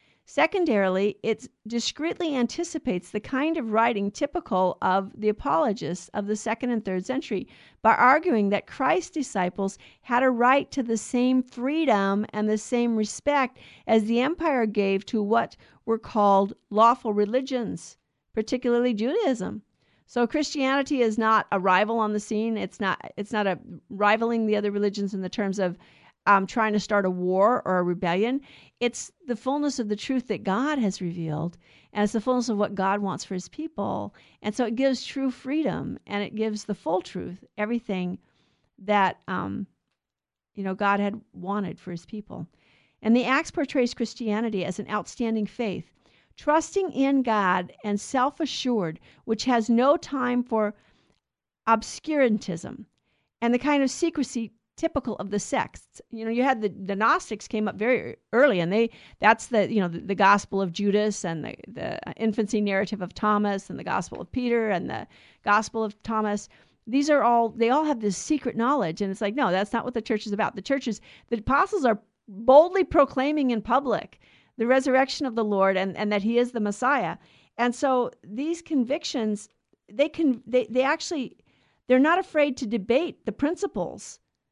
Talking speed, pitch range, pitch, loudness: 175 wpm, 205-255 Hz, 225 Hz, -25 LUFS